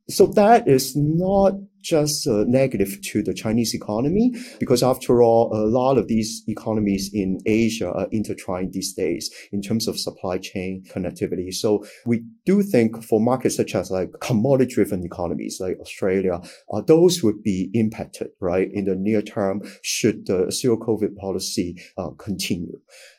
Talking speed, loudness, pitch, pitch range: 155 wpm, -21 LUFS, 110 Hz, 100-135 Hz